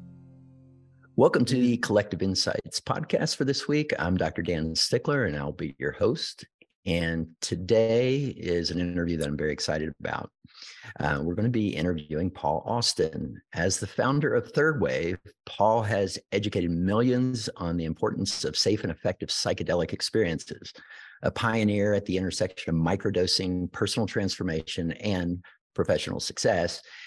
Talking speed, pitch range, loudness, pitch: 150 wpm, 85-115 Hz, -27 LUFS, 95 Hz